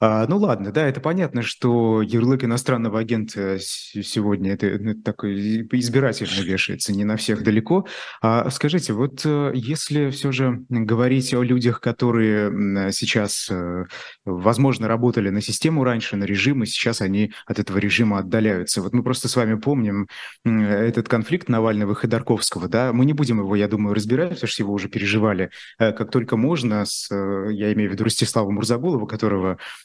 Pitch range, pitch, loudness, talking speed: 105-125 Hz, 115 Hz, -21 LUFS, 165 wpm